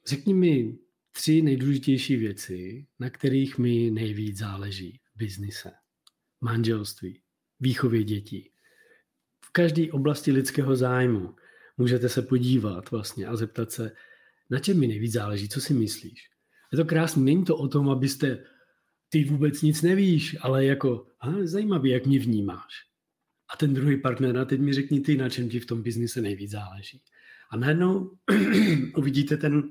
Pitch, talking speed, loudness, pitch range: 130 Hz, 150 wpm, -25 LUFS, 115-150 Hz